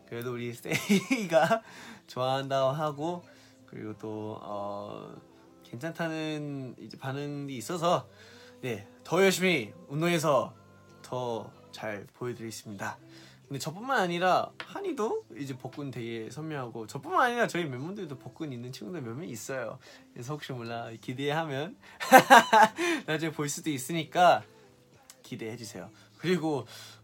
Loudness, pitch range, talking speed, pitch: -29 LUFS, 115-165 Hz, 275 characters per minute, 135 Hz